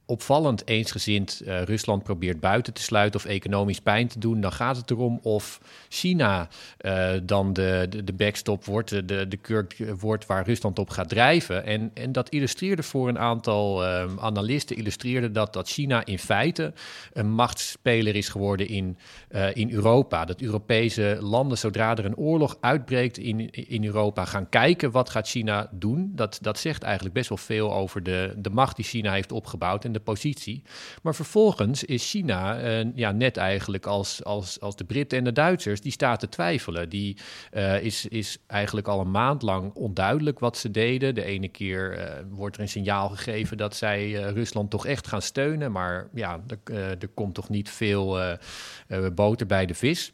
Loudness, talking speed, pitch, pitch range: -26 LUFS, 190 wpm, 105 Hz, 100-120 Hz